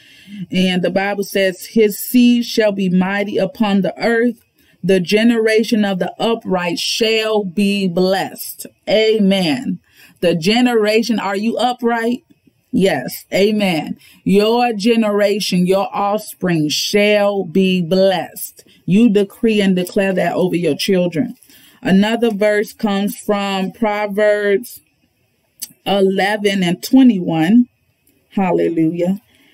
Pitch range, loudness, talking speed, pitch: 190-220 Hz, -16 LUFS, 105 wpm, 205 Hz